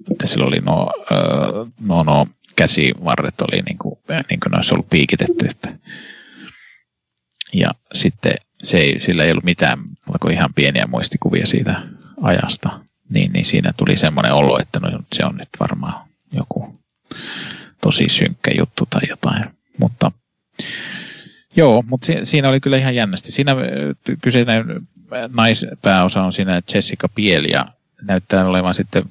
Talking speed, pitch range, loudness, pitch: 135 wpm, 90-130 Hz, -17 LUFS, 110 Hz